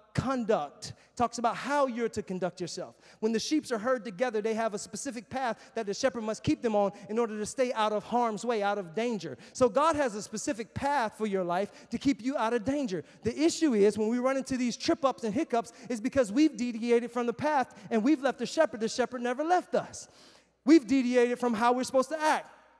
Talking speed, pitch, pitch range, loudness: 235 wpm, 240 Hz, 220-265 Hz, -29 LUFS